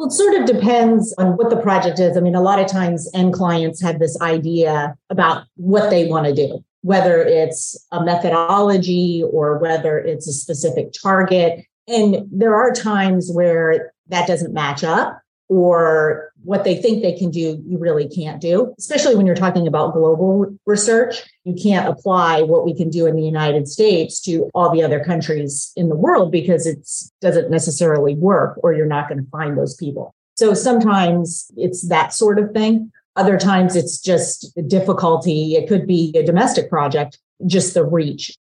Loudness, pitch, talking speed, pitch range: -17 LUFS, 175 Hz, 185 wpm, 160-195 Hz